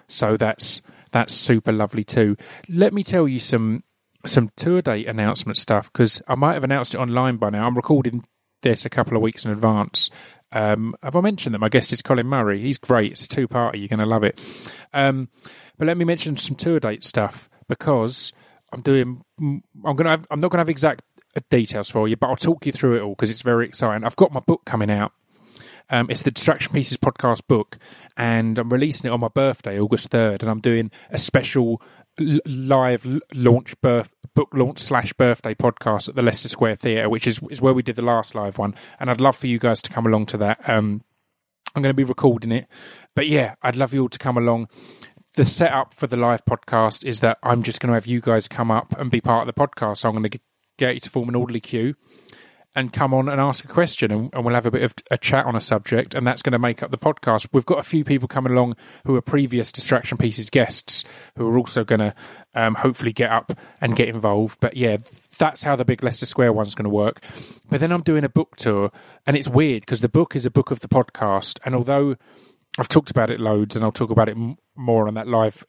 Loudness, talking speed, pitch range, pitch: -20 LUFS, 235 wpm, 115-135 Hz, 120 Hz